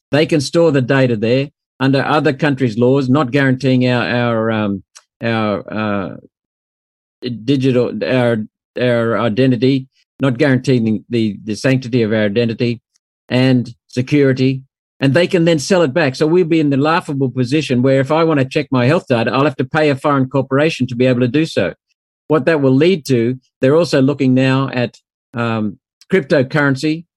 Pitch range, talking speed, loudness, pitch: 120-145 Hz, 175 wpm, -15 LUFS, 130 Hz